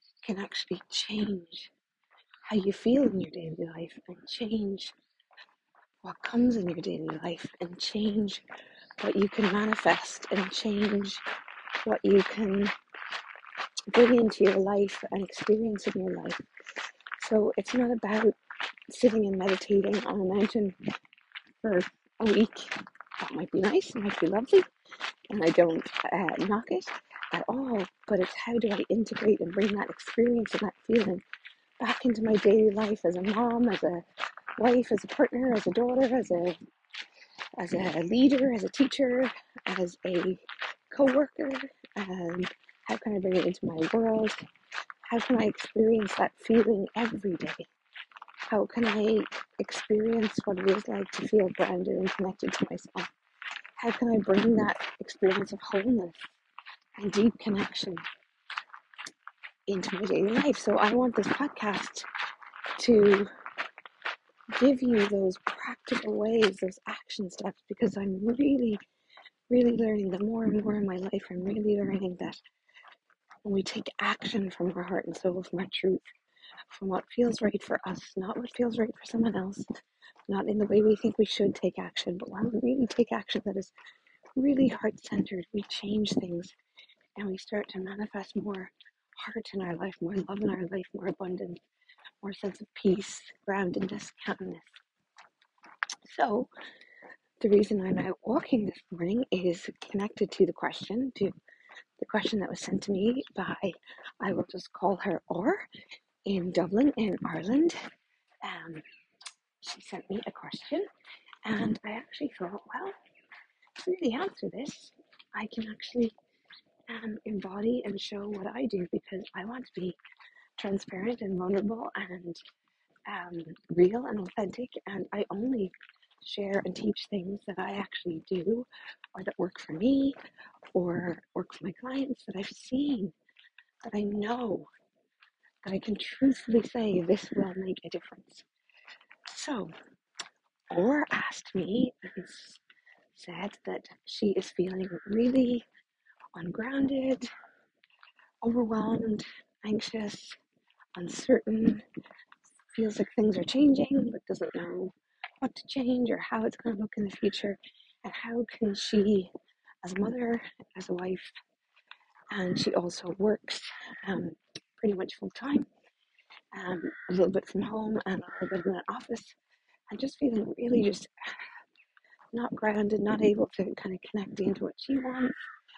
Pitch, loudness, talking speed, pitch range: 210 Hz, -30 LUFS, 155 wpm, 190-240 Hz